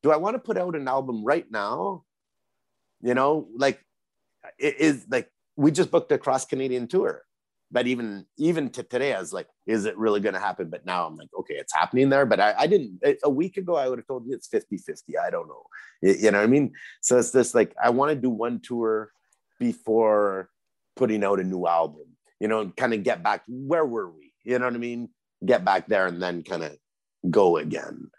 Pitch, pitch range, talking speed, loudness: 125 Hz, 110-155 Hz, 230 wpm, -25 LUFS